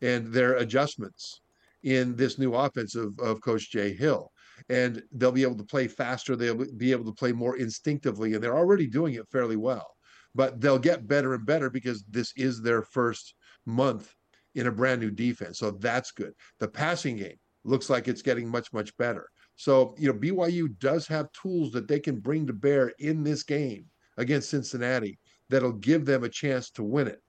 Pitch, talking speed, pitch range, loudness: 130 Hz, 195 wpm, 120-140 Hz, -28 LUFS